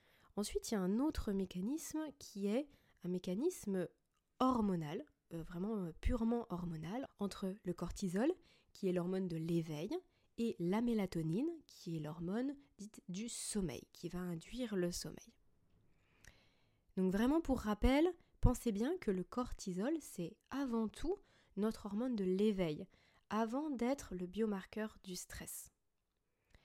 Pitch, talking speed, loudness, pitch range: 205 Hz, 135 wpm, -41 LUFS, 180-250 Hz